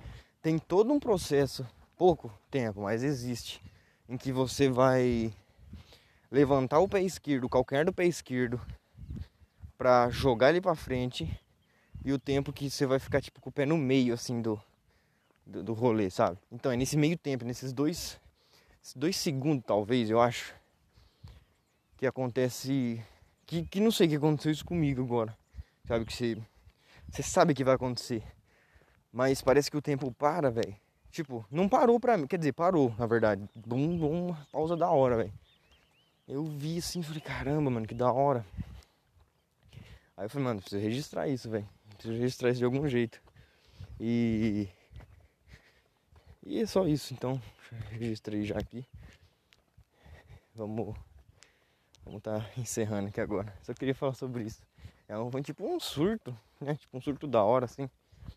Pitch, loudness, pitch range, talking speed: 125 Hz, -31 LUFS, 110-140 Hz, 160 wpm